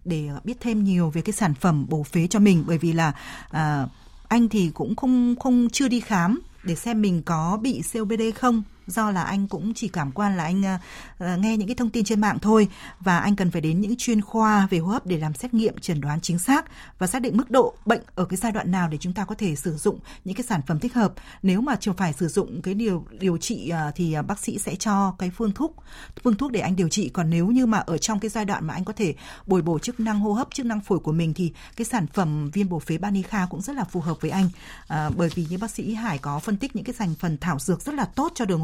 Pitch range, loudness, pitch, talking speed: 170-225 Hz, -24 LUFS, 195 Hz, 270 wpm